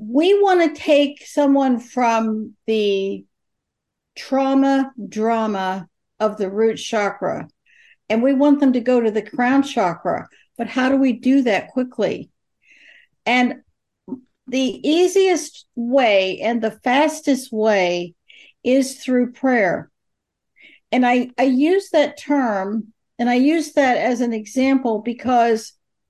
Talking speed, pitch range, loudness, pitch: 125 wpm, 220-275 Hz, -19 LUFS, 250 Hz